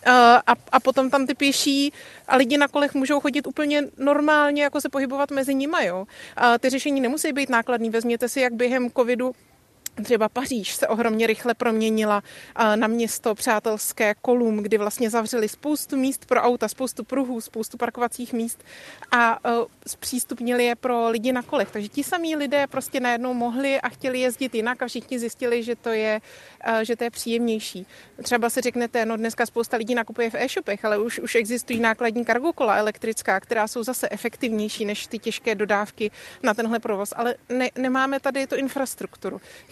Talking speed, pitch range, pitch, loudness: 175 wpm, 225-265 Hz, 240 Hz, -23 LUFS